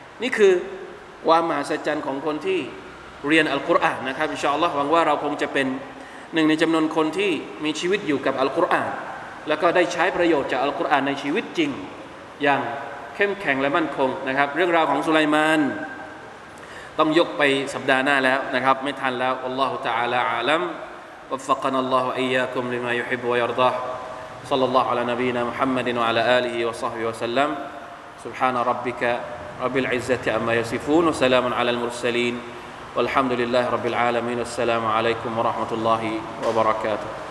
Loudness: -22 LUFS